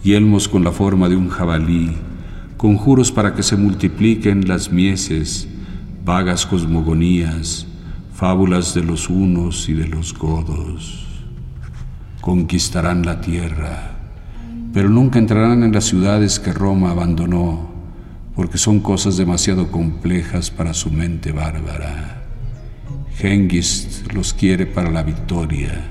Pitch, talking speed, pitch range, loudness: 90 Hz, 120 wpm, 85-100 Hz, -17 LUFS